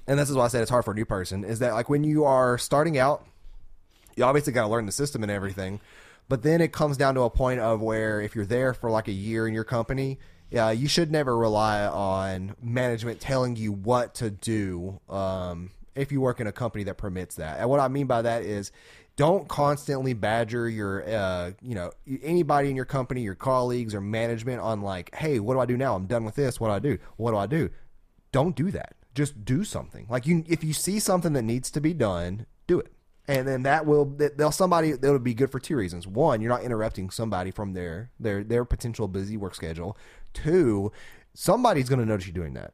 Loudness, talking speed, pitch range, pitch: -26 LUFS, 230 wpm, 100-135 Hz, 115 Hz